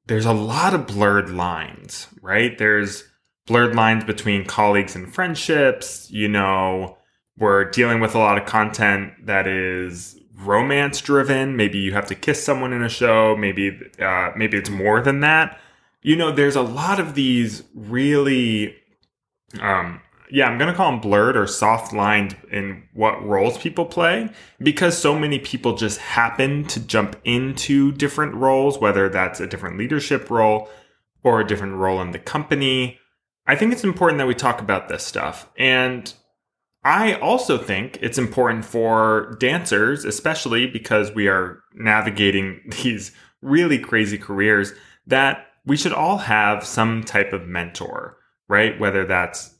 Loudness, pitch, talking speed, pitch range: -19 LUFS, 110 Hz, 155 wpm, 100-135 Hz